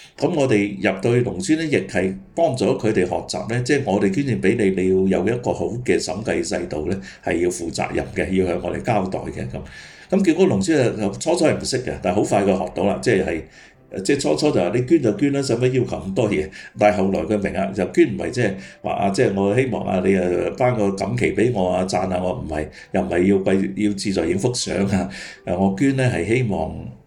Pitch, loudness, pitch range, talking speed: 100 Hz, -20 LUFS, 90-120 Hz, 330 characters per minute